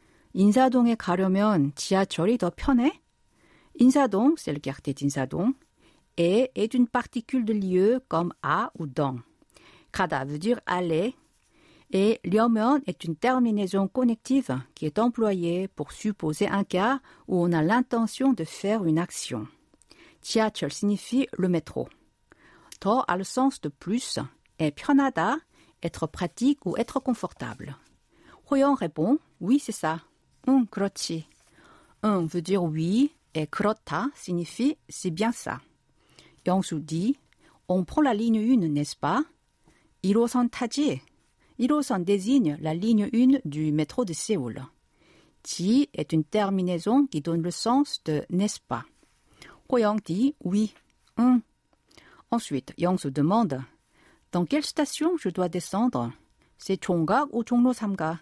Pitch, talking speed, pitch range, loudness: 205 Hz, 135 wpm, 170-250 Hz, -26 LUFS